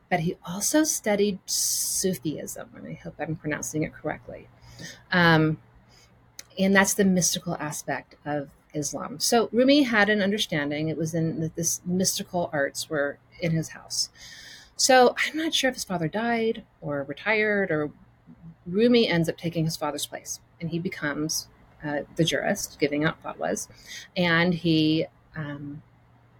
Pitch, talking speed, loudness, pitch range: 165 Hz, 150 wpm, -25 LUFS, 150-195 Hz